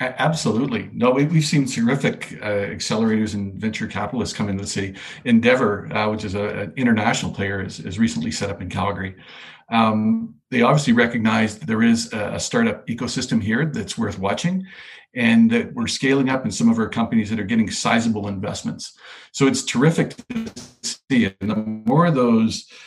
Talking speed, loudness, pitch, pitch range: 180 wpm, -21 LUFS, 115 Hz, 105-170 Hz